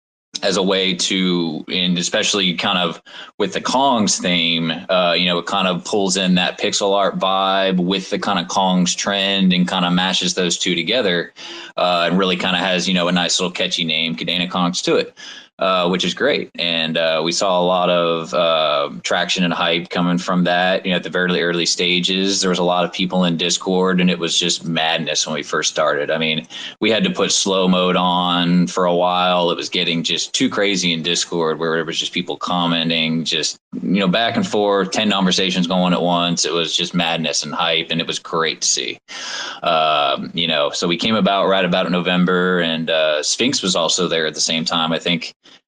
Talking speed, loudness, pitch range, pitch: 220 wpm, -17 LUFS, 85-90 Hz, 90 Hz